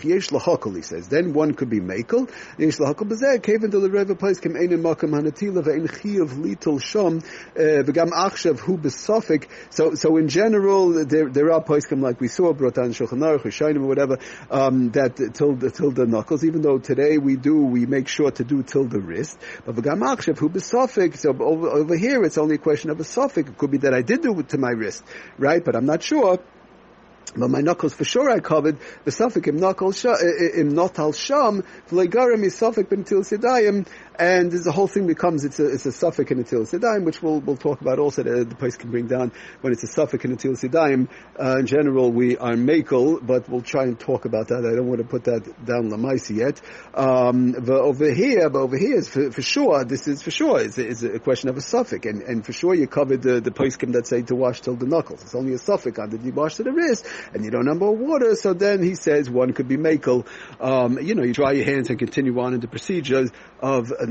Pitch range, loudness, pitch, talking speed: 130-175 Hz, -21 LUFS, 150 Hz, 220 wpm